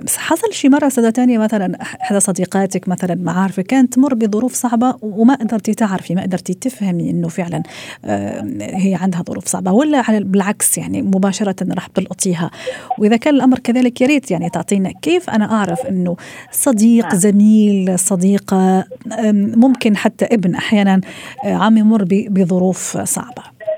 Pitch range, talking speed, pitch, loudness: 190-240 Hz, 150 wpm, 210 Hz, -15 LUFS